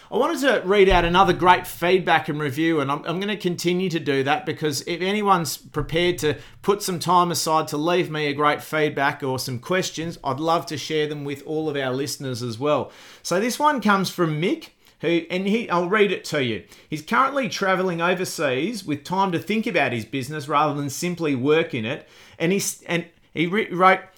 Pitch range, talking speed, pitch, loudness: 150-185 Hz, 210 wpm, 165 Hz, -22 LUFS